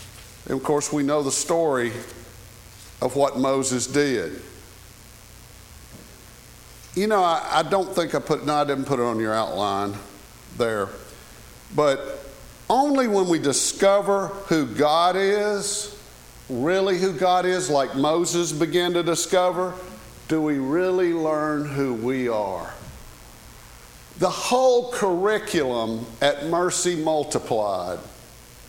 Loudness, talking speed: -22 LUFS, 120 wpm